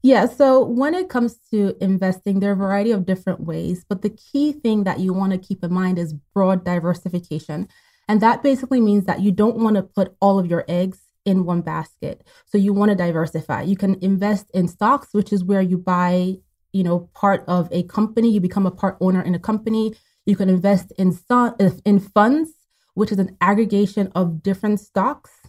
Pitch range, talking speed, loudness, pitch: 185-210 Hz, 205 wpm, -20 LUFS, 195 Hz